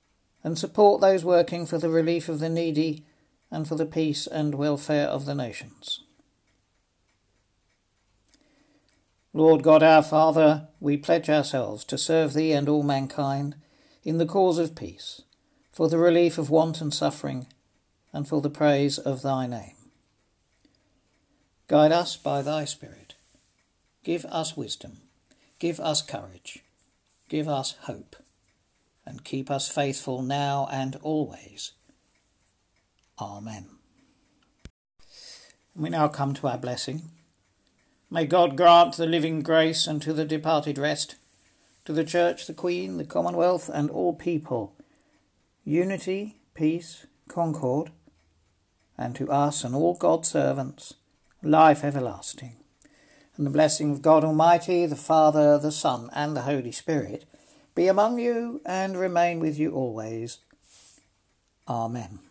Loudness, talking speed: -24 LUFS, 130 wpm